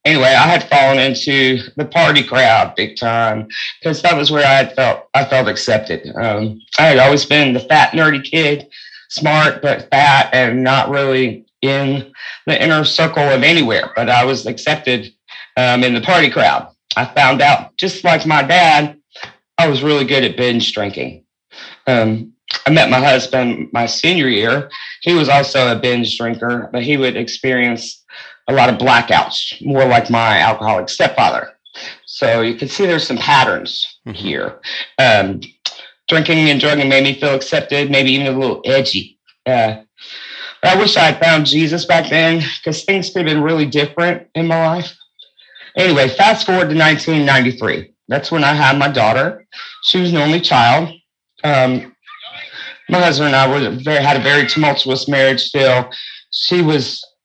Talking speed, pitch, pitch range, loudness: 170 wpm, 140 Hz, 125-155 Hz, -13 LUFS